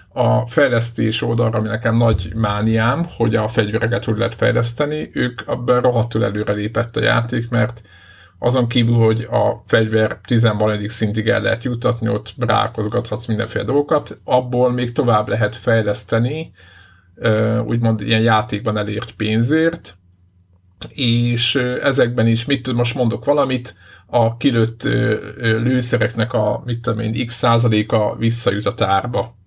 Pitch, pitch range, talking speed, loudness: 115 Hz, 105-120 Hz, 125 wpm, -18 LUFS